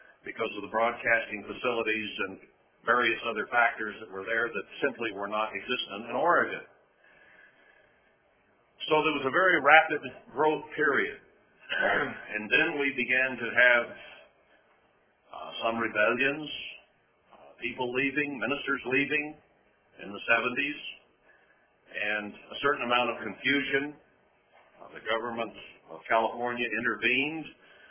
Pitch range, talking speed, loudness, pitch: 115-140 Hz, 120 wpm, -28 LUFS, 125 Hz